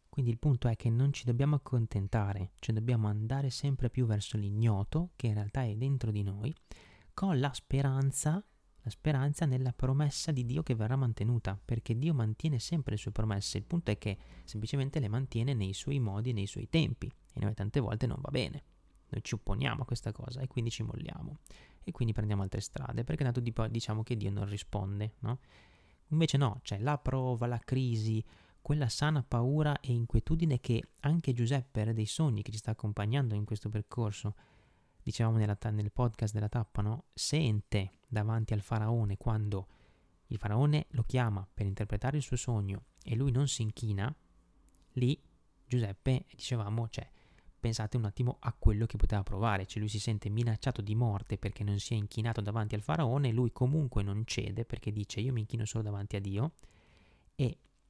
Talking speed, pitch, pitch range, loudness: 190 wpm, 115 Hz, 105-130 Hz, -34 LUFS